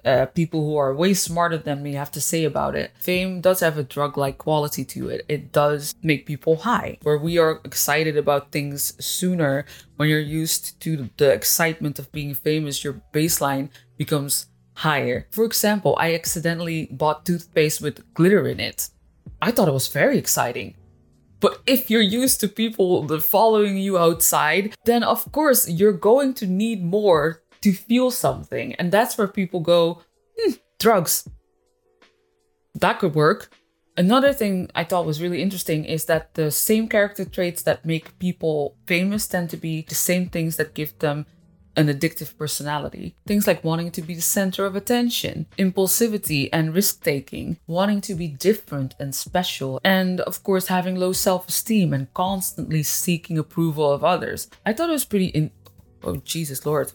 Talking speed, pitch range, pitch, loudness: 170 wpm, 150-190 Hz, 165 Hz, -21 LUFS